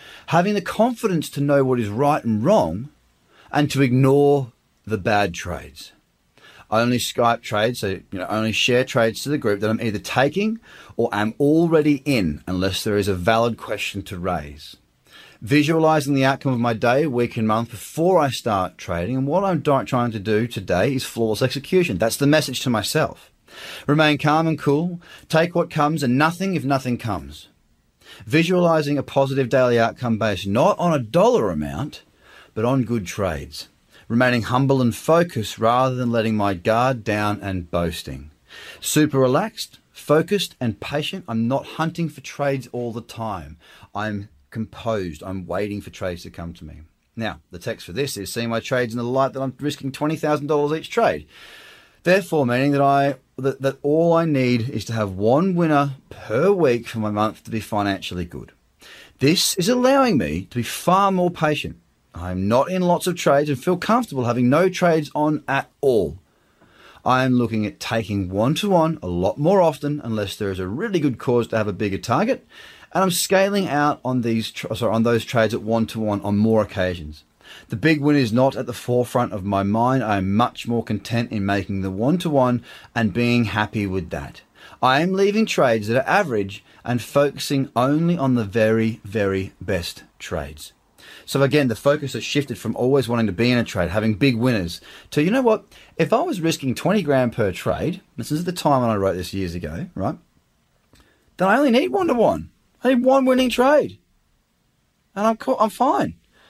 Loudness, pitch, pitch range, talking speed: -21 LUFS, 125 Hz, 110-150 Hz, 190 wpm